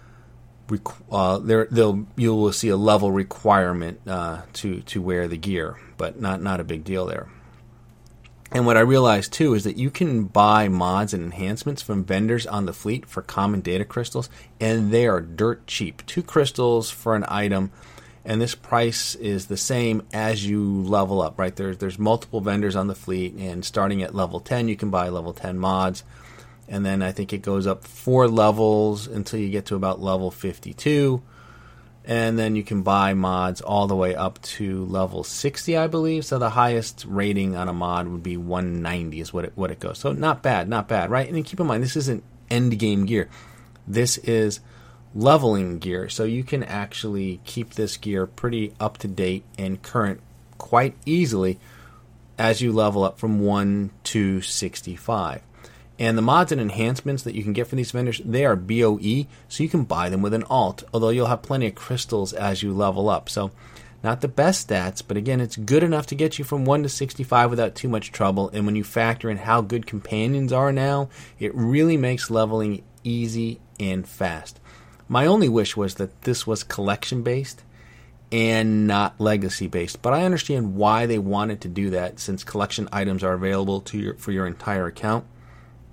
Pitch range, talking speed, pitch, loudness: 95-120 Hz, 190 wpm, 110 Hz, -23 LUFS